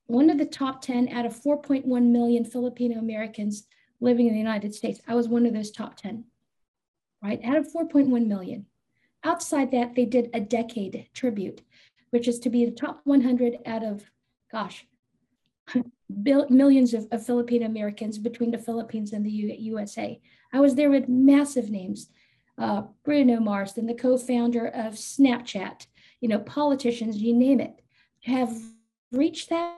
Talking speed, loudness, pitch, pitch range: 160 wpm, -25 LUFS, 240 Hz, 225-260 Hz